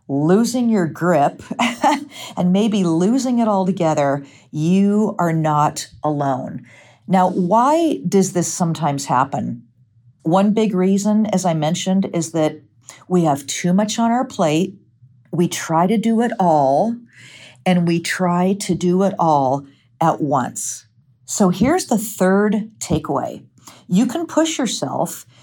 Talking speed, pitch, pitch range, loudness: 135 wpm, 180 Hz, 150-210 Hz, -18 LUFS